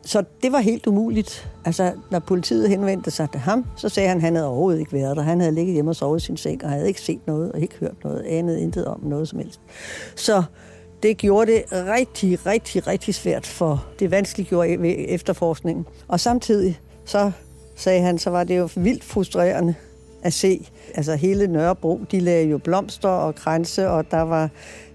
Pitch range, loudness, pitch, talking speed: 160-200 Hz, -21 LUFS, 180 Hz, 200 wpm